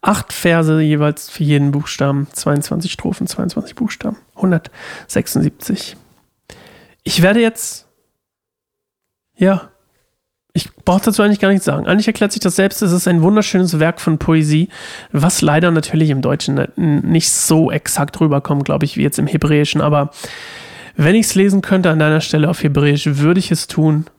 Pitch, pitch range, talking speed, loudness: 165 Hz, 150-195 Hz, 160 wpm, -15 LUFS